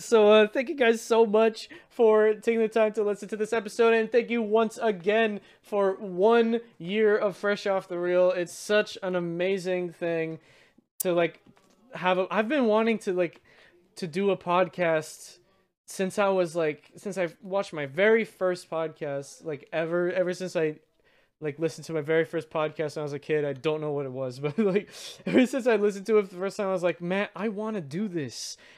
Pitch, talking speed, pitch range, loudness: 190 Hz, 215 wpm, 165-215 Hz, -26 LUFS